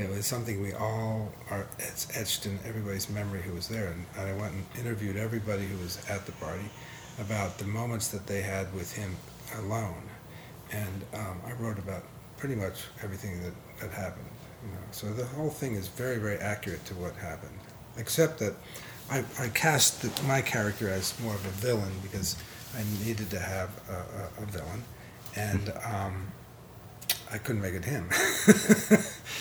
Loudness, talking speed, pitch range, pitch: -32 LUFS, 175 wpm, 95-120 Hz, 105 Hz